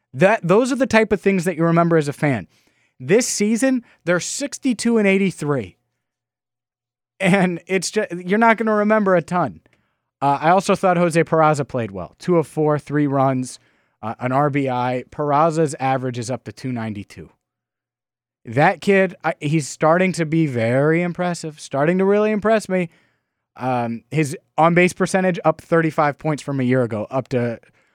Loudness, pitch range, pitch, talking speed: -19 LUFS, 130-185 Hz, 160 Hz, 170 wpm